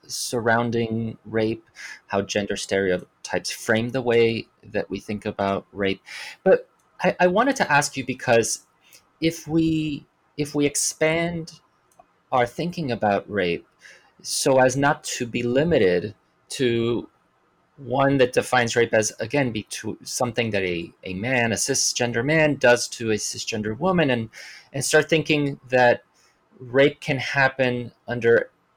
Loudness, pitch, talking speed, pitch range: -22 LUFS, 125 Hz, 140 wpm, 115-145 Hz